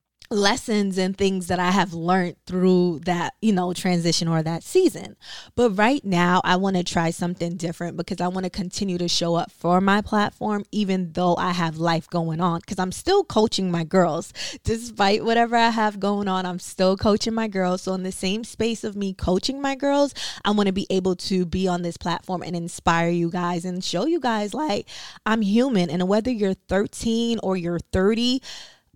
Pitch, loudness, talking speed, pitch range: 185 Hz, -23 LUFS, 200 wpm, 175-215 Hz